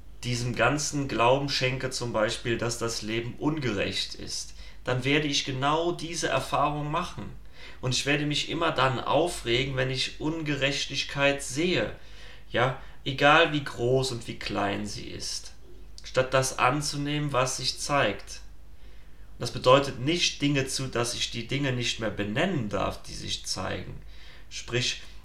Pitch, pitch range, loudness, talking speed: 130 Hz, 115-145 Hz, -27 LUFS, 145 wpm